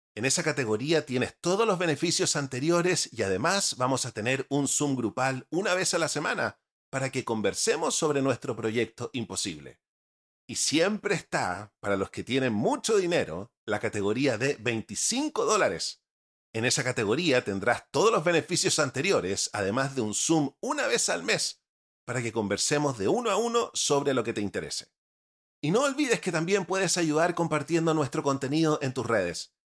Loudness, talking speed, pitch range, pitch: -27 LUFS, 165 wpm, 115-165 Hz, 135 Hz